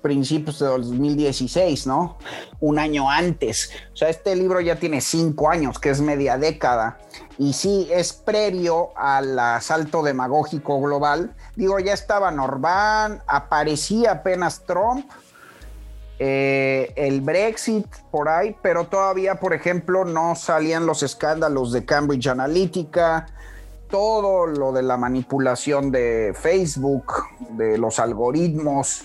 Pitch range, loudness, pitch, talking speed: 135-175 Hz, -21 LUFS, 150 Hz, 125 wpm